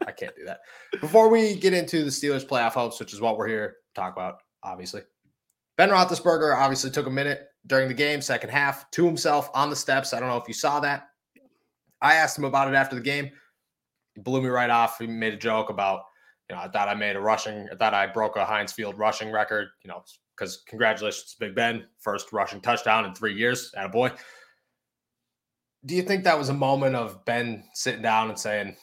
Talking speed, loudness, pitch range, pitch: 225 wpm, -25 LUFS, 110-145 Hz, 135 Hz